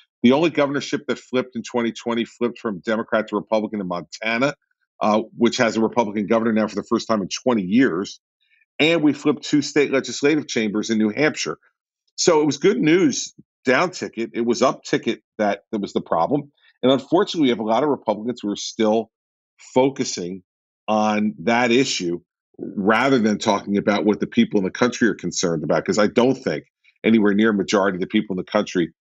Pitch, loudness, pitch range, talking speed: 115 Hz, -21 LUFS, 105-135 Hz, 200 wpm